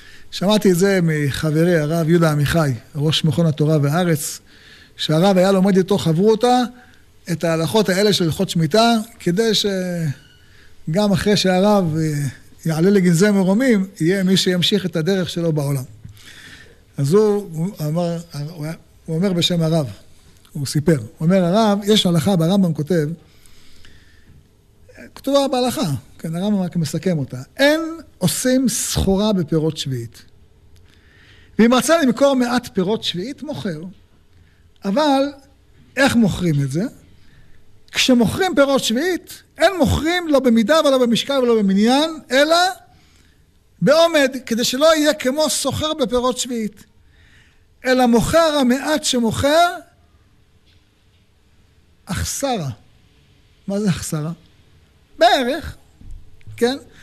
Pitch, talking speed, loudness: 180 Hz, 115 wpm, -17 LUFS